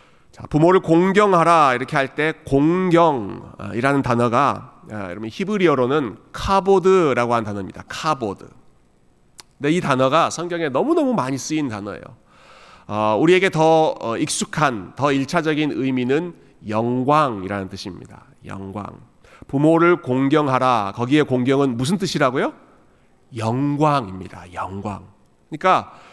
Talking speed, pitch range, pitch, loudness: 280 characters per minute, 105-160 Hz, 135 Hz, -19 LUFS